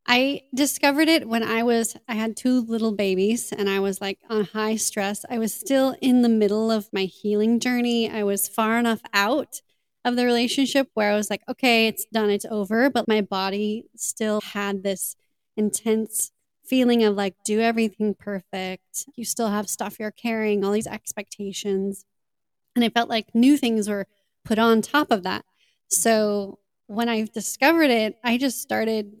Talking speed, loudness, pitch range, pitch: 180 wpm, -23 LUFS, 205-235 Hz, 220 Hz